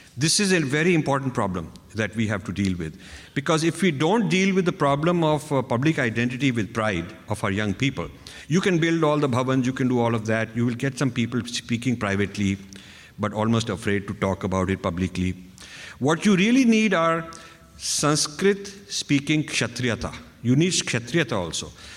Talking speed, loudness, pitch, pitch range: 190 wpm, -23 LUFS, 125 Hz, 100-160 Hz